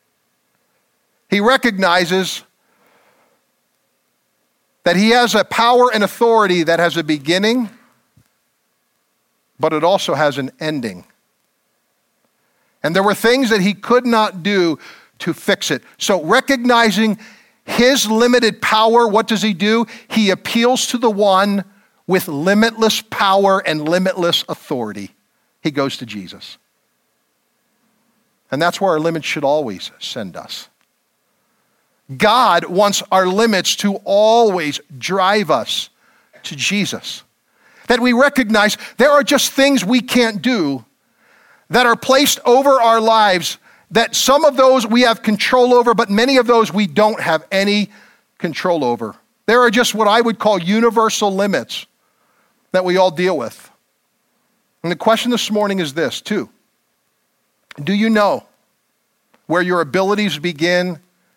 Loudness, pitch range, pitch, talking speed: -15 LUFS, 180-235 Hz, 210 Hz, 135 wpm